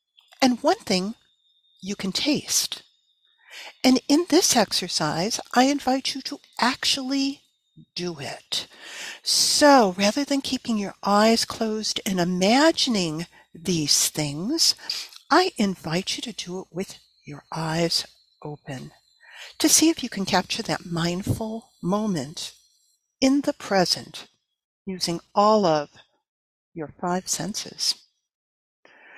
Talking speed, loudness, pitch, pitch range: 115 wpm, -22 LUFS, 200 Hz, 175-265 Hz